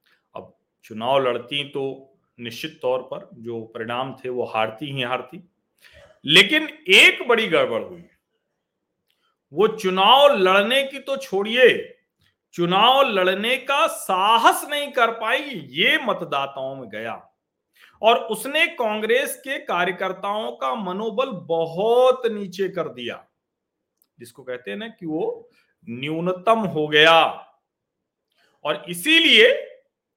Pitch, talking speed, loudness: 200 Hz, 115 wpm, -19 LUFS